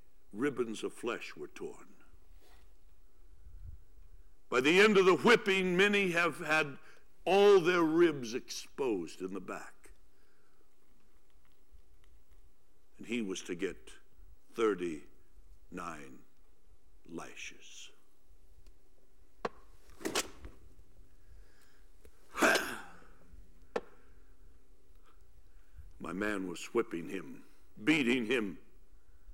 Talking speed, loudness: 70 wpm, -31 LUFS